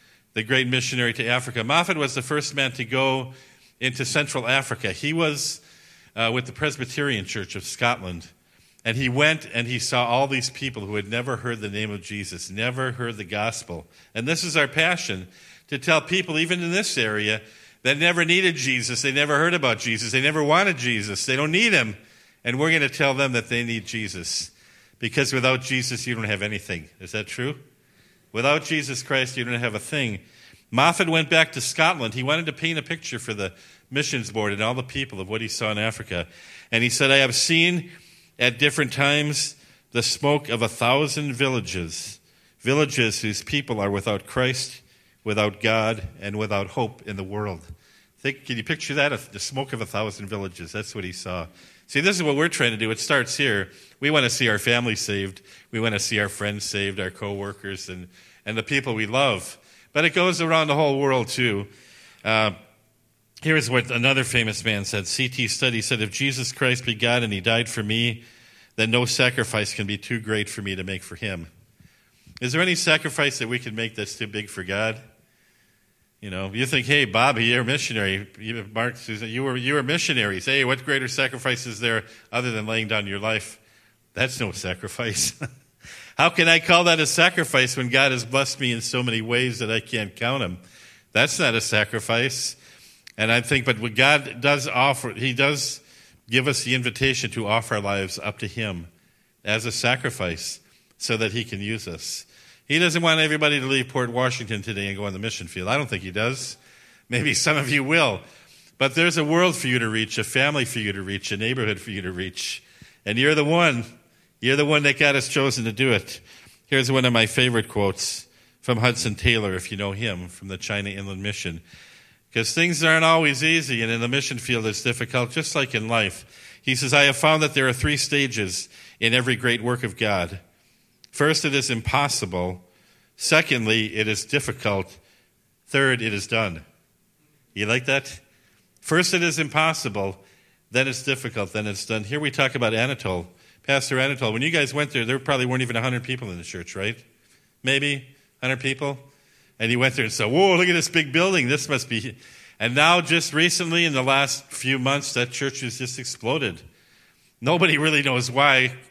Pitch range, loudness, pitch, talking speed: 110-140 Hz, -22 LUFS, 120 Hz, 205 wpm